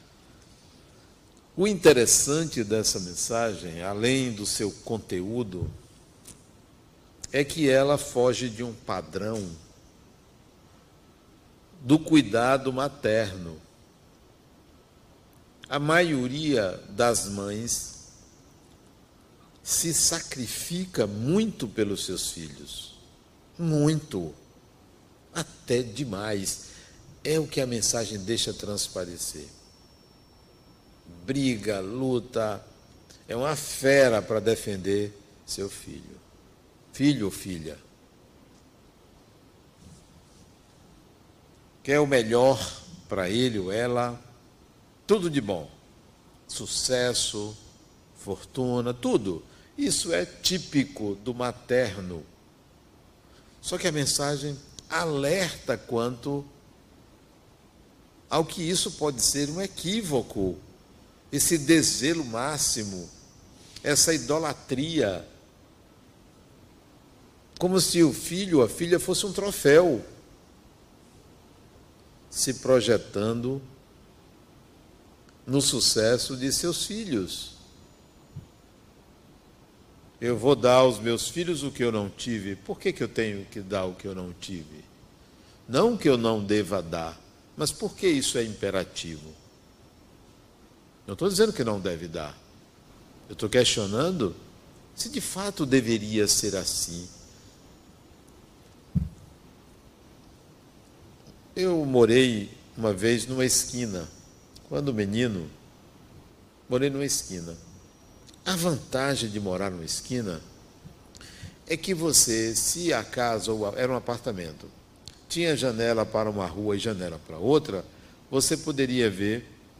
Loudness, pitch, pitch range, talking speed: -26 LUFS, 120 Hz, 100-140 Hz, 95 wpm